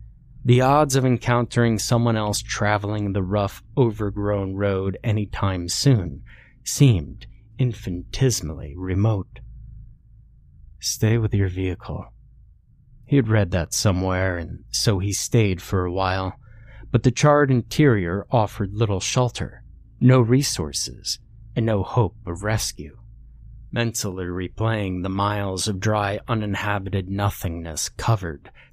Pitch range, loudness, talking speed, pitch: 95-120 Hz, -22 LUFS, 115 wpm, 105 Hz